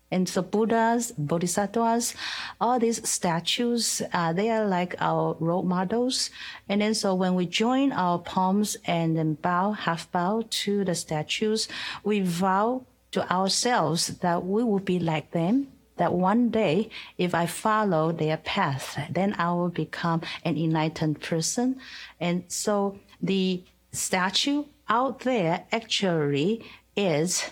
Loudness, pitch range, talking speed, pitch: -26 LUFS, 170-220 Hz, 135 wpm, 190 Hz